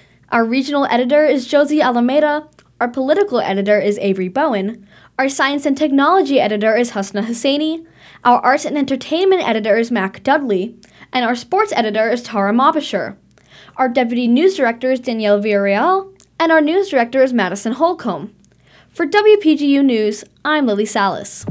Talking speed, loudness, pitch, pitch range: 155 wpm, -16 LUFS, 255 Hz, 215-295 Hz